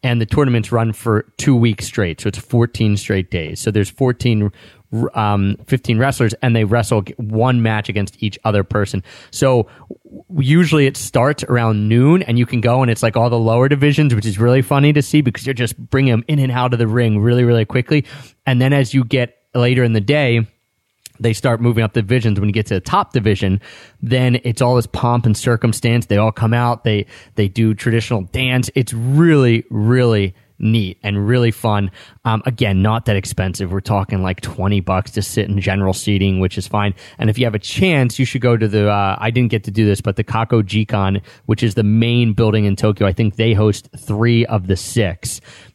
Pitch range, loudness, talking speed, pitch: 105-125 Hz, -16 LUFS, 215 wpm, 115 Hz